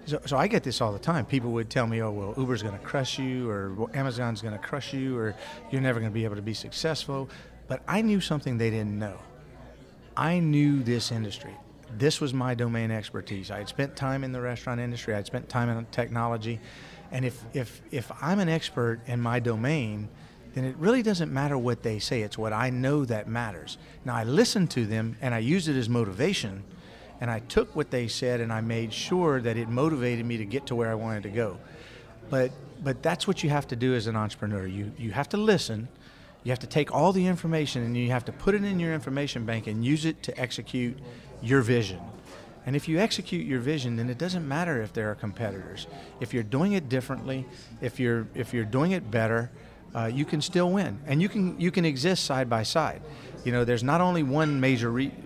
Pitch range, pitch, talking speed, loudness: 115-145 Hz, 125 Hz, 230 wpm, -28 LUFS